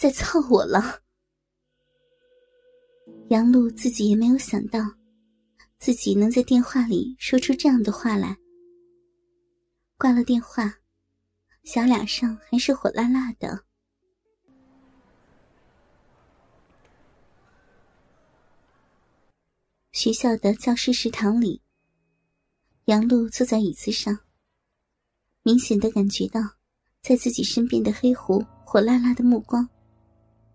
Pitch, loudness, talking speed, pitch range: 240 Hz, -22 LUFS, 145 characters per minute, 220-265 Hz